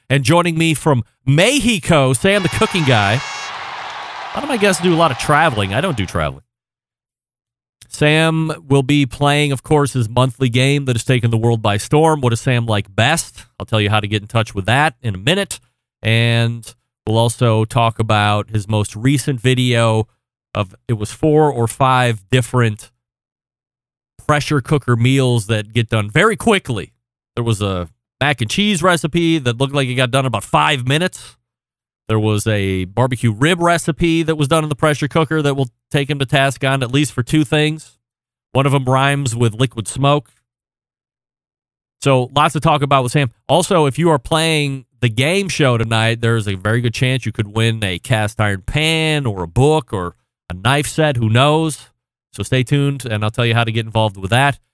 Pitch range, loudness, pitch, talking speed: 115-150 Hz, -16 LUFS, 125 Hz, 195 wpm